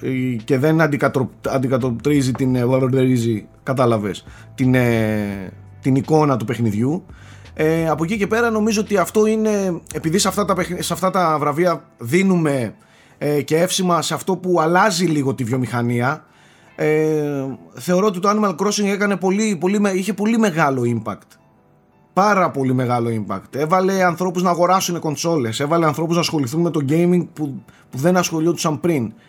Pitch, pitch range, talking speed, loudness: 155 Hz, 130-180 Hz, 150 wpm, -18 LUFS